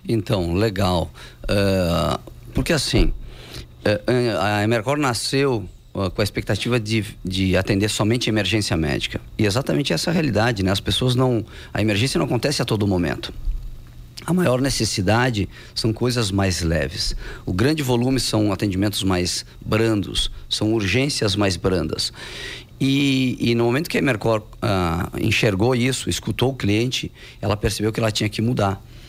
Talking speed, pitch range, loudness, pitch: 155 wpm, 95-125 Hz, -21 LUFS, 110 Hz